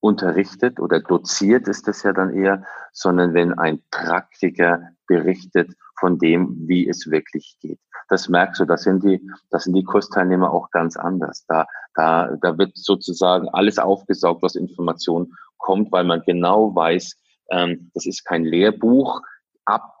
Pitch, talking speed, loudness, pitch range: 90 Hz, 155 wpm, -19 LUFS, 85-95 Hz